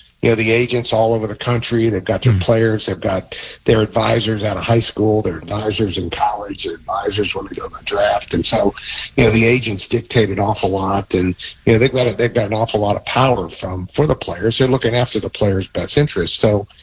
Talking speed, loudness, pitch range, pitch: 240 wpm, -17 LUFS, 100-115 Hz, 110 Hz